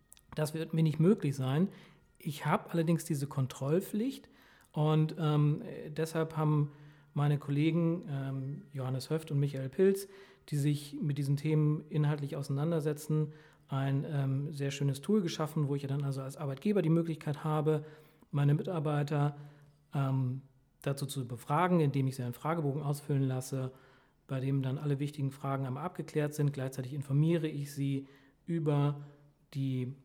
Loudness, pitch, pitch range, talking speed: -33 LUFS, 145 Hz, 140-155 Hz, 150 wpm